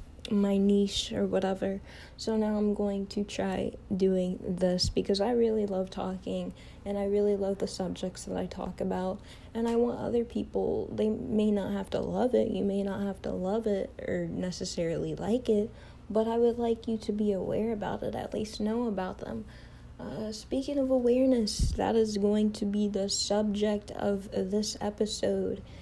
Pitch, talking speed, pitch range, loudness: 205 Hz, 185 wpm, 185-220 Hz, -30 LUFS